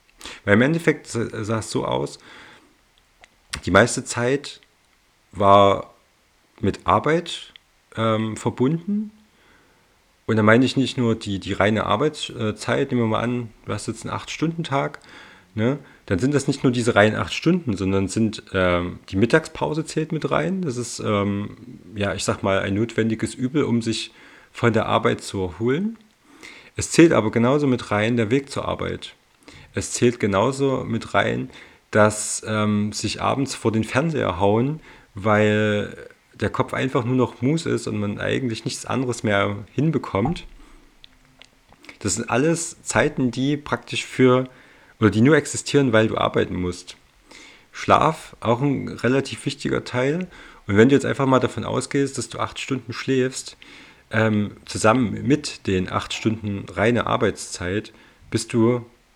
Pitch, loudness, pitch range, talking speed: 115 Hz, -22 LUFS, 105-135 Hz, 155 wpm